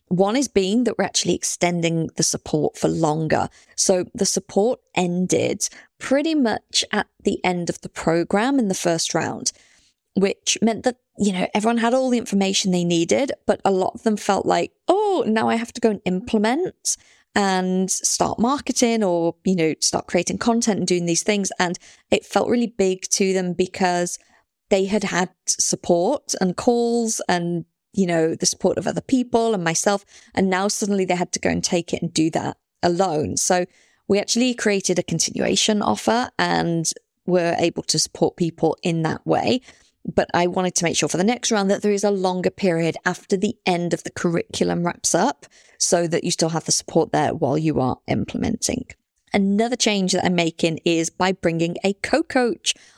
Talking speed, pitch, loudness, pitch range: 190 wpm, 190 Hz, -21 LUFS, 175-220 Hz